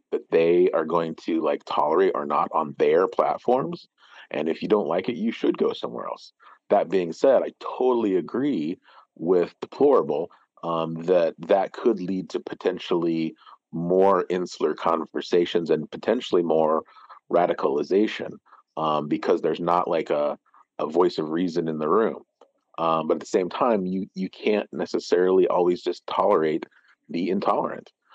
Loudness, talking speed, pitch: -24 LUFS, 155 wpm, 95 Hz